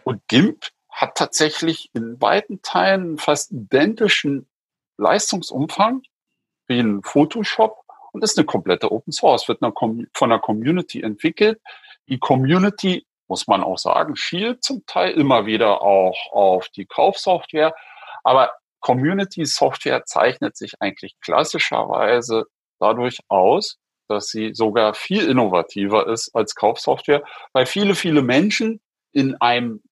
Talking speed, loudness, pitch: 125 wpm, -19 LUFS, 155 Hz